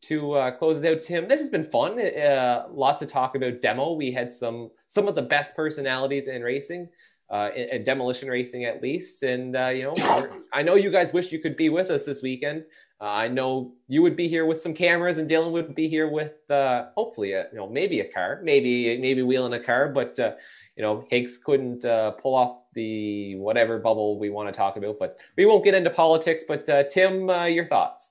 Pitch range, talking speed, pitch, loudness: 125-165 Hz, 230 wpm, 140 Hz, -24 LUFS